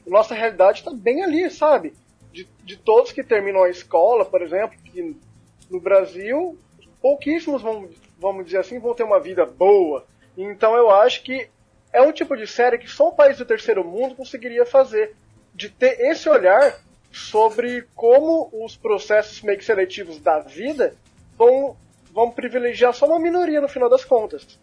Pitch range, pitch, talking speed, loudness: 220-320 Hz, 255 Hz, 170 wpm, -19 LUFS